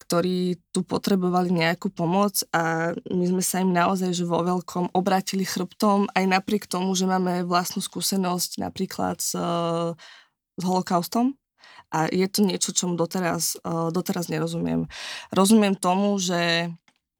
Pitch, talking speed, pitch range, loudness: 180 Hz, 140 wpm, 170-195 Hz, -24 LUFS